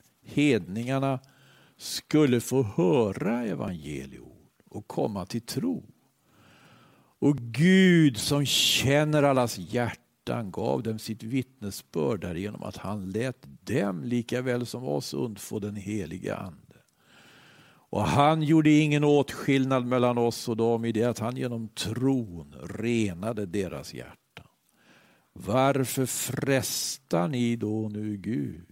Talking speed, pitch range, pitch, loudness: 115 wpm, 105-135 Hz, 120 Hz, -27 LUFS